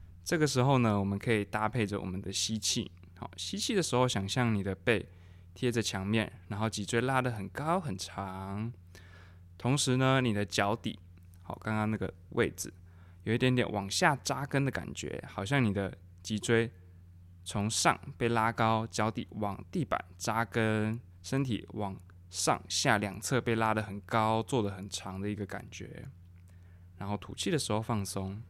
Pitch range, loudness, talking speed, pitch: 95-120 Hz, -32 LUFS, 240 characters per minute, 105 Hz